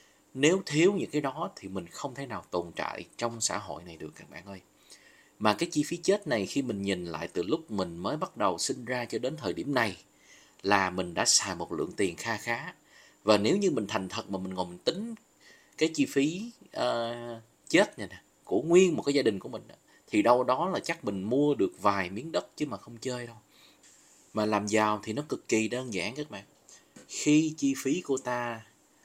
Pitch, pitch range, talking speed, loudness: 120 Hz, 100-150 Hz, 225 wpm, -29 LUFS